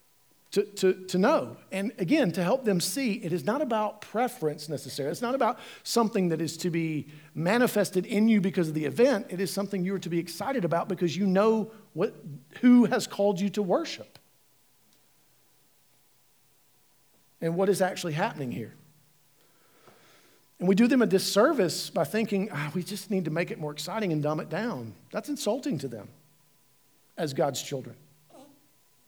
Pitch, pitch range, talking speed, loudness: 190 Hz, 165-215 Hz, 175 wpm, -28 LUFS